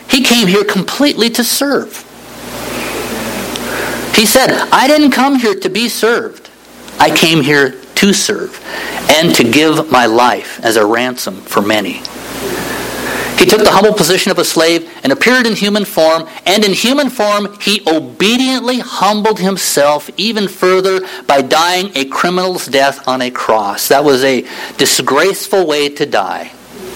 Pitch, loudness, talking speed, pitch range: 190 Hz, -11 LUFS, 150 wpm, 155-220 Hz